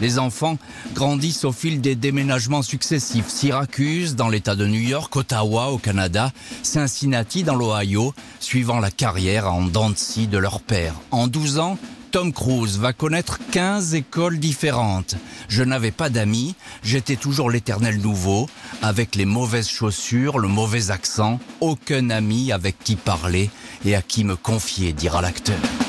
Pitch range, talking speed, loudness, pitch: 105-140 Hz, 150 wpm, -21 LUFS, 120 Hz